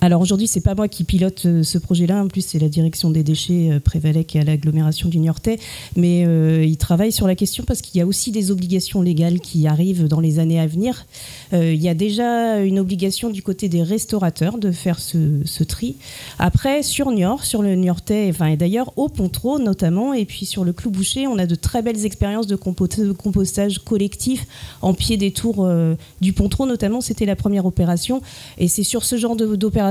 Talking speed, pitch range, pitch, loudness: 210 wpm, 165-210 Hz, 185 Hz, -19 LUFS